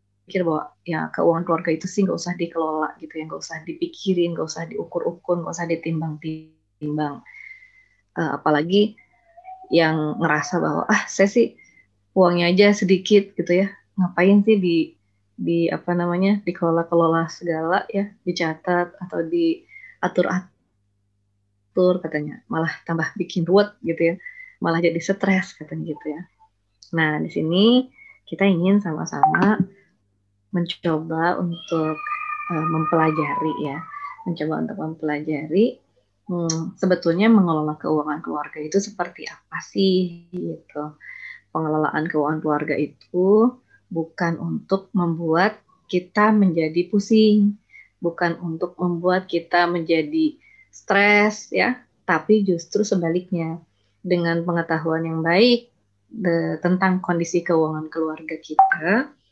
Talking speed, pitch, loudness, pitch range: 120 wpm, 175 Hz, -21 LUFS, 160-195 Hz